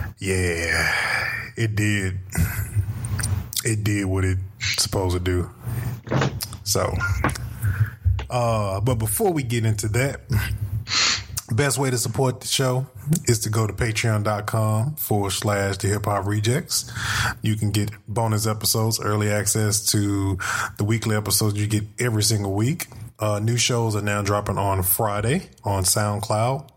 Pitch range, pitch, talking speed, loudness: 100-115 Hz, 105 Hz, 135 wpm, -23 LUFS